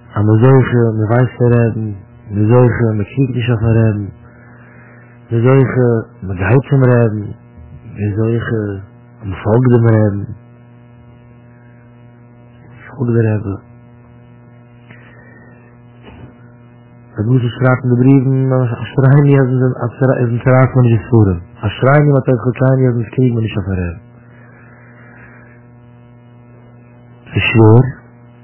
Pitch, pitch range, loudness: 120 Hz, 115-120 Hz, -13 LUFS